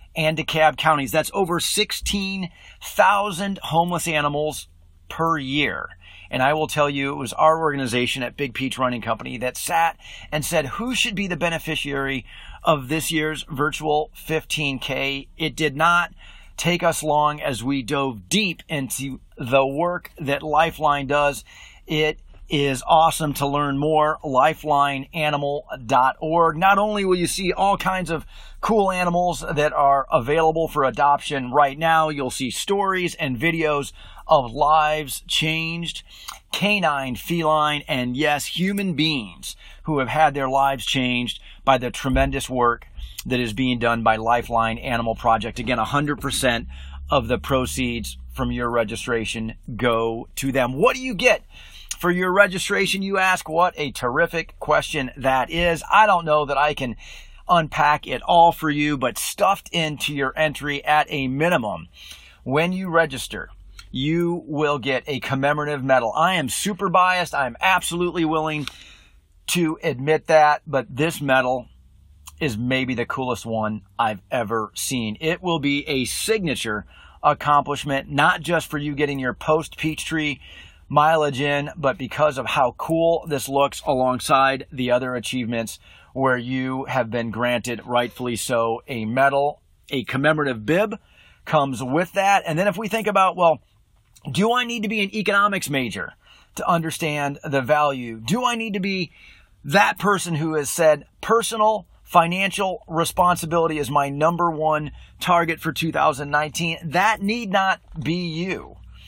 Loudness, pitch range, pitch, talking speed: -21 LUFS, 130-165 Hz, 150 Hz, 150 wpm